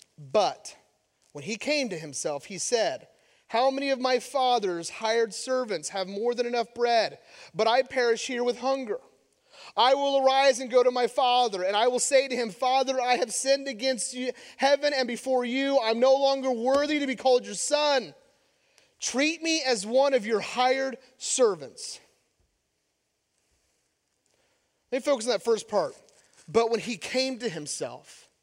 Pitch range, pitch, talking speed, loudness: 230-275 Hz, 255 Hz, 170 wpm, -26 LUFS